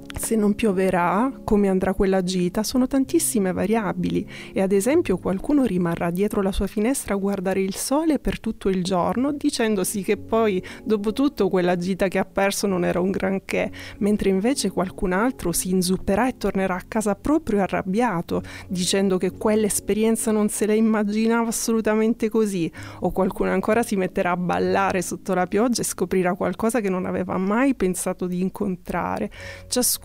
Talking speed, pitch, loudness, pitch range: 165 wpm, 195 Hz, -22 LUFS, 185-220 Hz